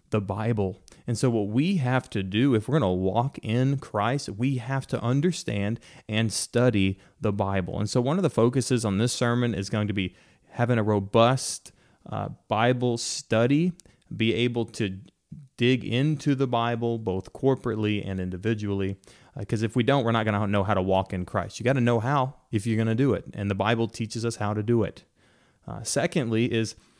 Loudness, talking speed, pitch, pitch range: -26 LUFS, 205 wpm, 115 Hz, 105-130 Hz